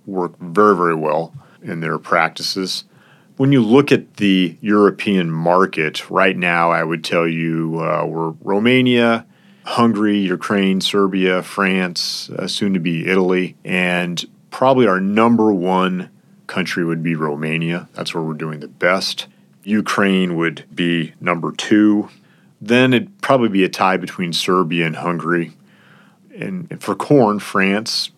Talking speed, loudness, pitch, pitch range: 145 wpm, -17 LUFS, 95 Hz, 85-105 Hz